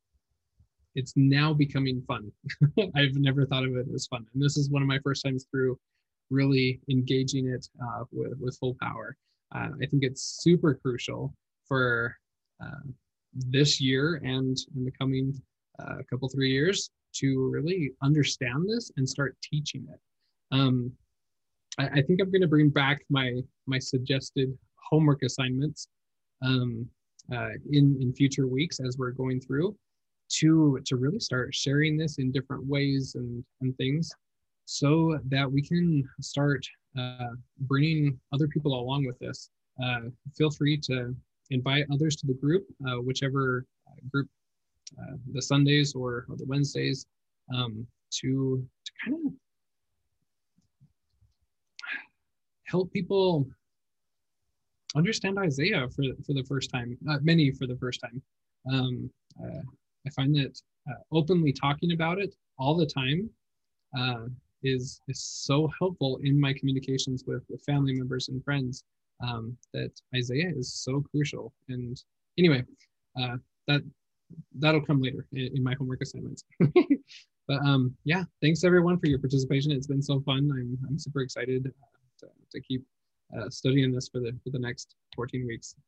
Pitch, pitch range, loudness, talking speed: 135 Hz, 125-145 Hz, -28 LUFS, 150 wpm